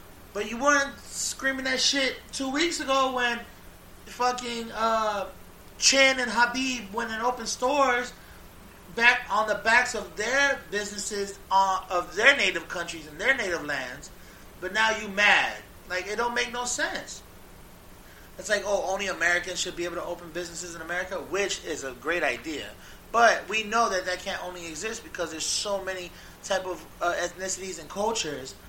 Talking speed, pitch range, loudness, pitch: 170 wpm, 180-245 Hz, -26 LUFS, 205 Hz